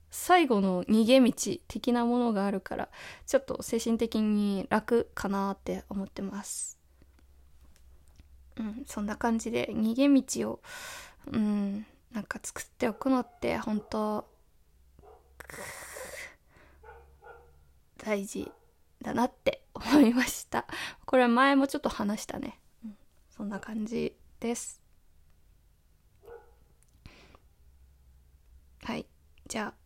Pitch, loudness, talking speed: 210 Hz, -30 LUFS, 195 characters per minute